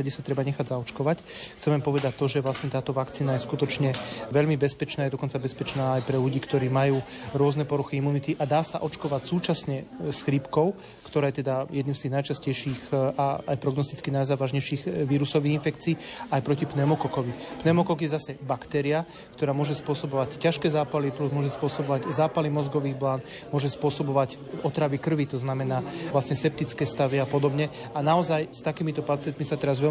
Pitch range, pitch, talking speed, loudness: 135-150 Hz, 145 Hz, 170 wpm, -27 LUFS